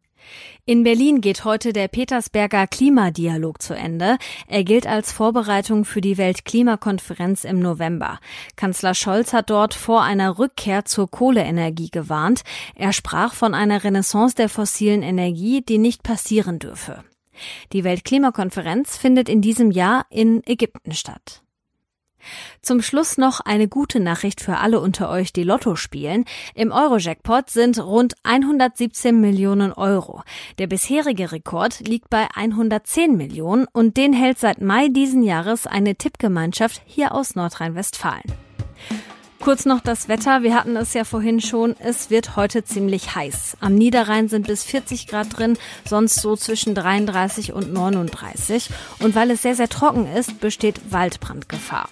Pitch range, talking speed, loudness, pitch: 195-235 Hz, 145 wpm, -19 LUFS, 220 Hz